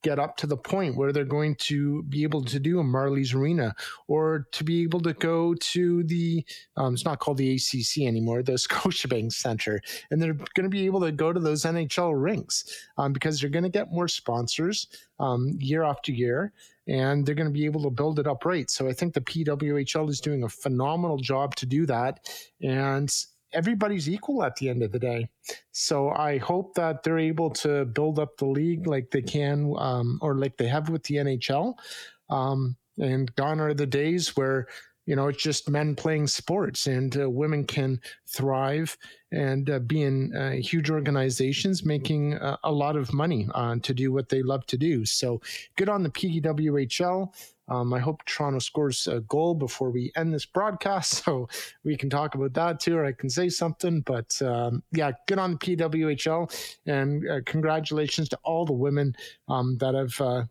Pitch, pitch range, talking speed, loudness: 145 Hz, 135-160 Hz, 200 wpm, -27 LUFS